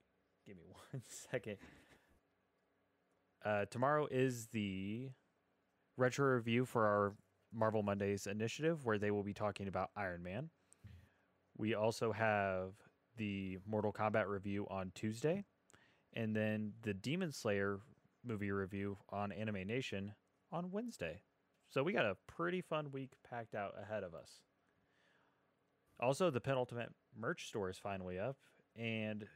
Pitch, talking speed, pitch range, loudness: 105 Hz, 135 wpm, 100-125 Hz, -41 LUFS